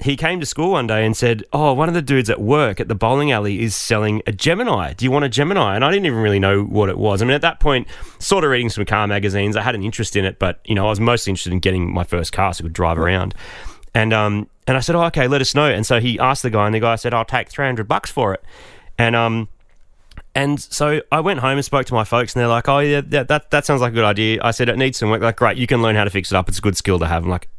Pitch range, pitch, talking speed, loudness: 100-135 Hz, 115 Hz, 320 wpm, -17 LUFS